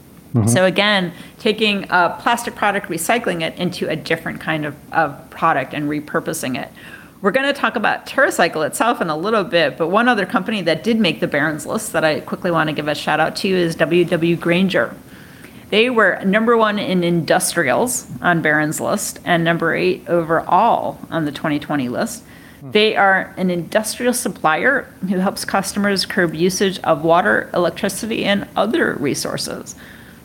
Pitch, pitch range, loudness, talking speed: 180 Hz, 165-215 Hz, -18 LUFS, 170 wpm